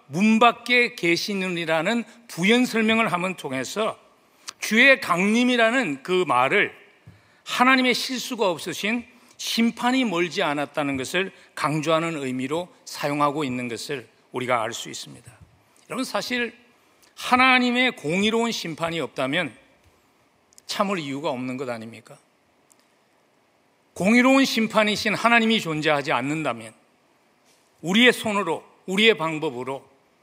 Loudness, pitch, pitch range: -22 LUFS, 195 Hz, 155-235 Hz